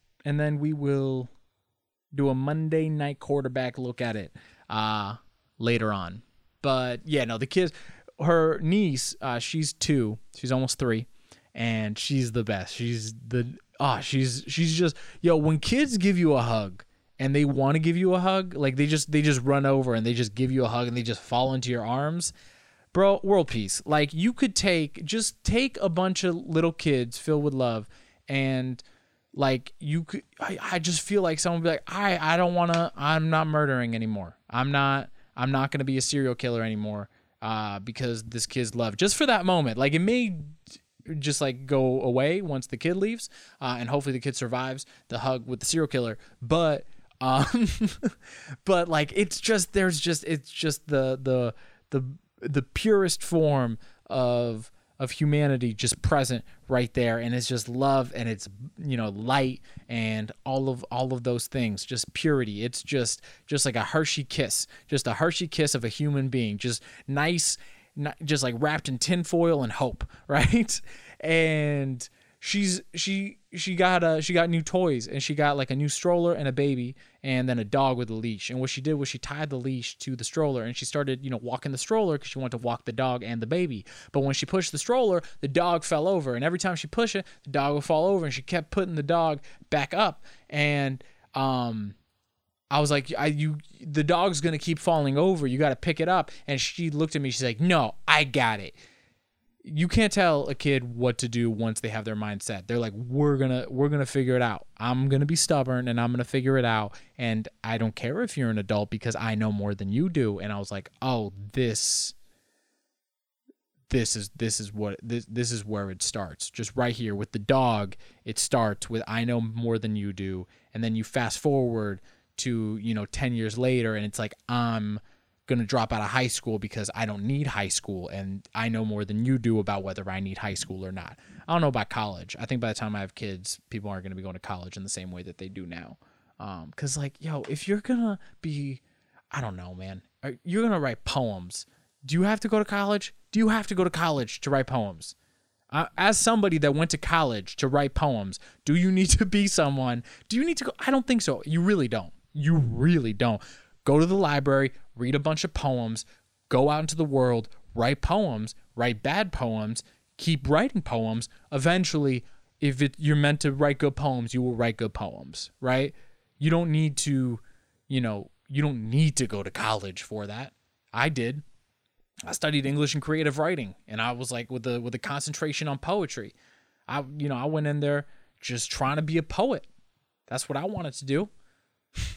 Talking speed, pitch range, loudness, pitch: 215 wpm, 115-155 Hz, -27 LUFS, 135 Hz